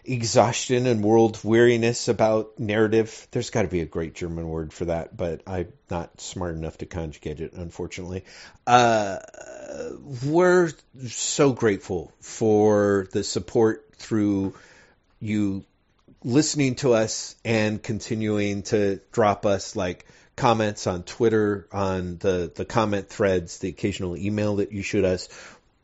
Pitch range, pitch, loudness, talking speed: 95-115 Hz, 105 Hz, -24 LUFS, 135 wpm